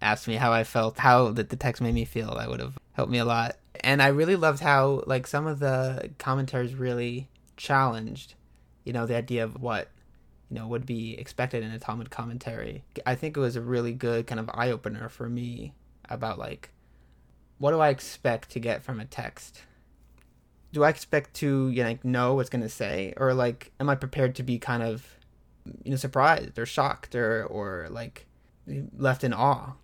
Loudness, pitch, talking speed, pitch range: -27 LUFS, 120 Hz, 205 wpm, 115-130 Hz